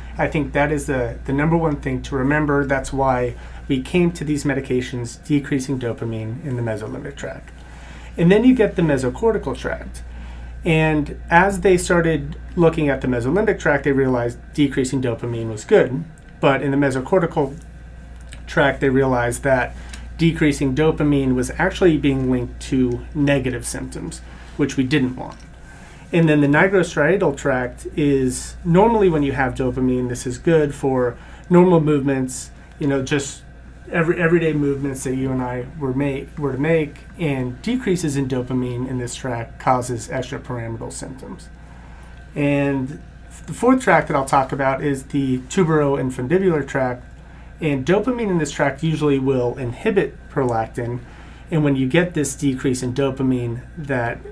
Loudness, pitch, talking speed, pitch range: -20 LUFS, 140 Hz, 155 wpm, 125-155 Hz